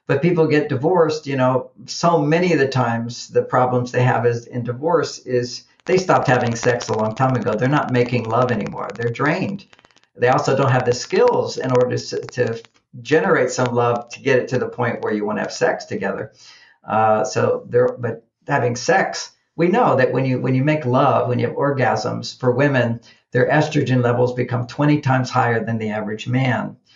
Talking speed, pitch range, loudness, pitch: 205 wpm, 120-145 Hz, -19 LUFS, 125 Hz